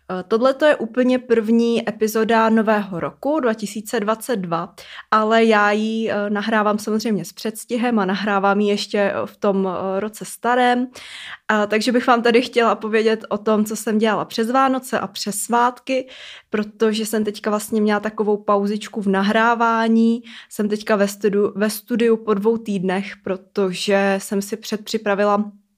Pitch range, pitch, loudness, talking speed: 205-230 Hz, 215 Hz, -19 LUFS, 145 wpm